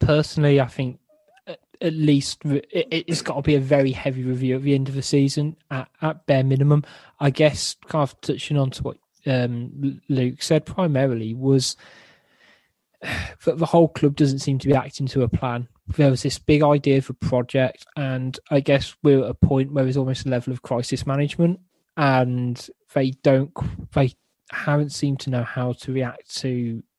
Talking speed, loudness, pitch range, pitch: 180 wpm, -22 LUFS, 130-150 Hz, 140 Hz